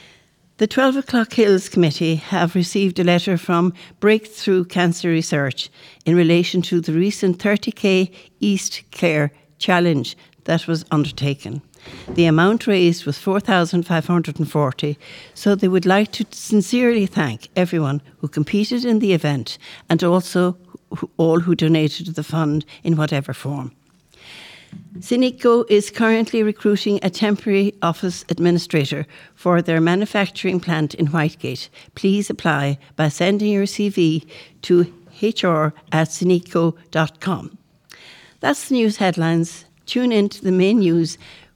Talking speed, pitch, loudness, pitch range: 125 wpm, 175 Hz, -19 LUFS, 160-200 Hz